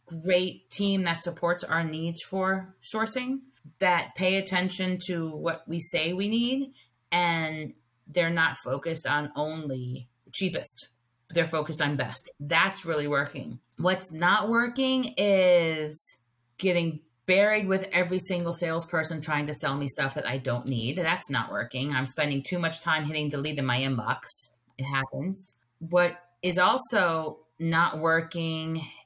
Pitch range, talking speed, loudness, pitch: 145-180 Hz, 145 wpm, -27 LUFS, 165 Hz